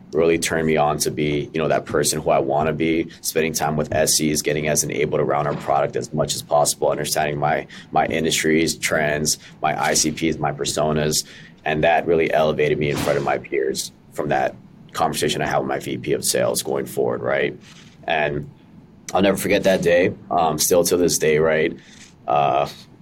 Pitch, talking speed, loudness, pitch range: 80 Hz, 195 wpm, -20 LUFS, 75-85 Hz